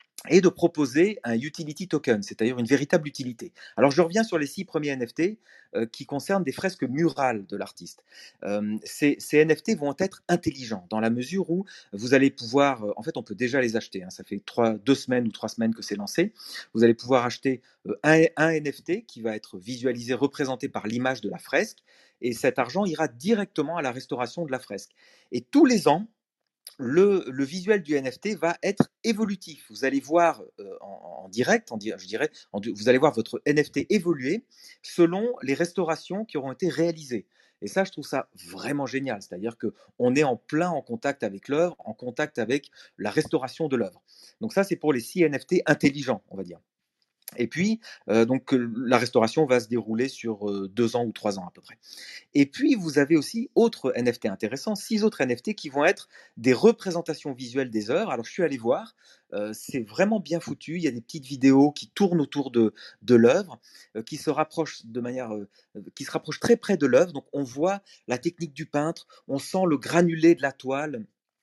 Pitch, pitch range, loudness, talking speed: 145 Hz, 120-170 Hz, -25 LUFS, 205 wpm